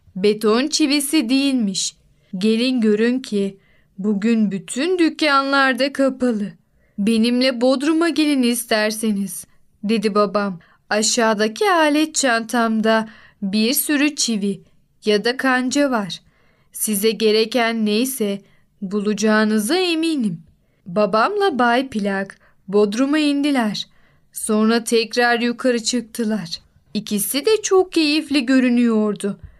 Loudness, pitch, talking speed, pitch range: -18 LUFS, 230 Hz, 90 wpm, 210-270 Hz